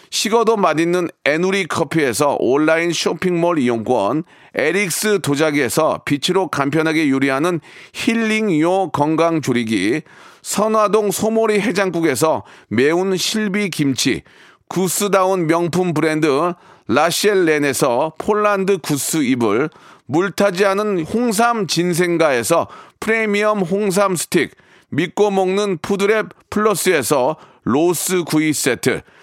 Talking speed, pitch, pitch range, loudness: 255 characters per minute, 185 Hz, 160-205 Hz, -17 LUFS